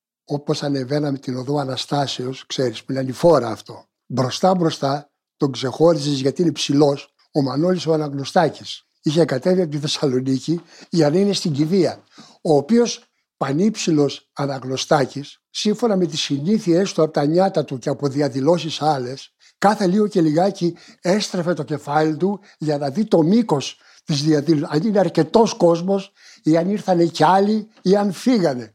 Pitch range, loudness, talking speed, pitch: 140-185 Hz, -19 LUFS, 155 wpm, 155 Hz